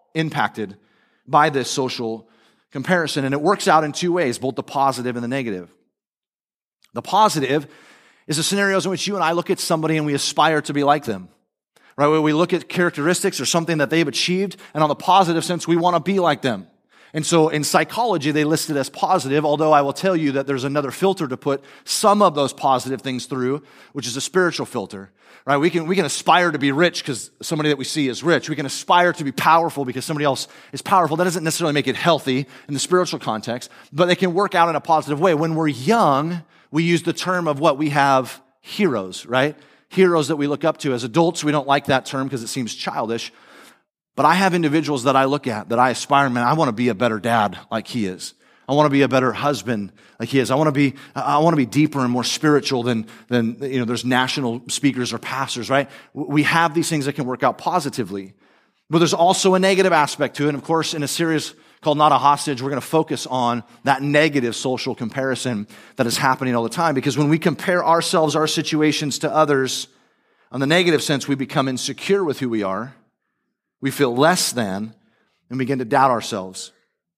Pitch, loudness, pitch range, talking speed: 145 Hz, -19 LUFS, 130-165 Hz, 230 wpm